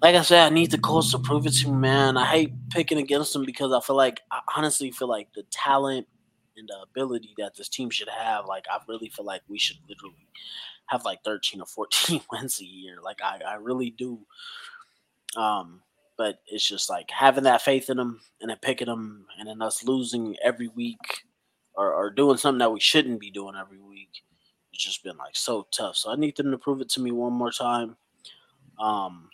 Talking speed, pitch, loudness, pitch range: 220 wpm, 125 Hz, -25 LUFS, 115-140 Hz